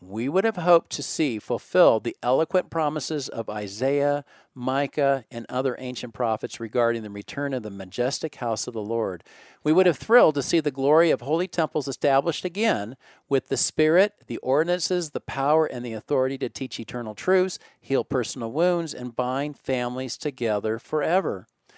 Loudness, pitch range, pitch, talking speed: -25 LUFS, 120-155 Hz, 135 Hz, 170 wpm